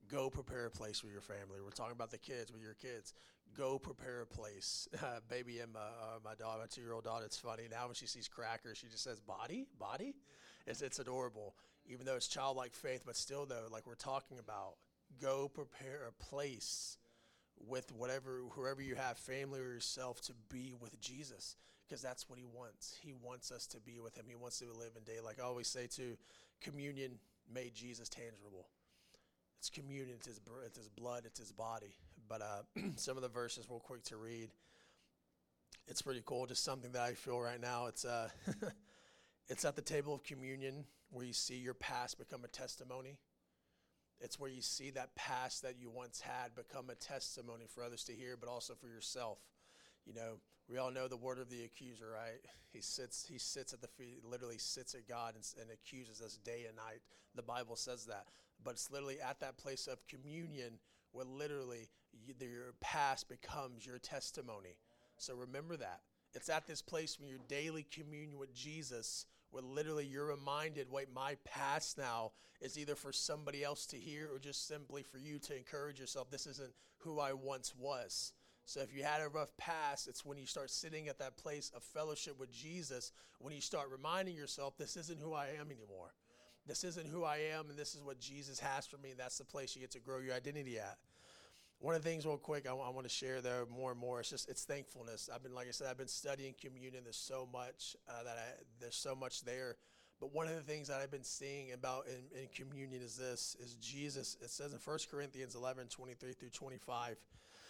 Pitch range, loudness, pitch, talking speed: 120-140 Hz, -47 LUFS, 130 Hz, 210 wpm